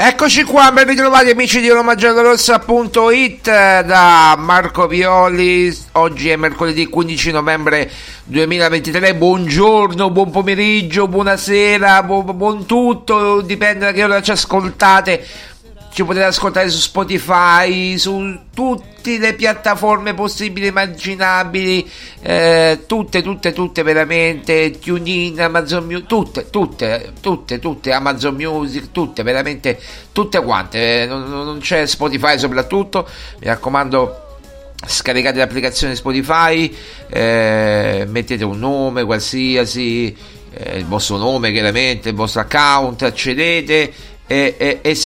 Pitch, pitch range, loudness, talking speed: 175 Hz, 140-200 Hz, -13 LUFS, 120 wpm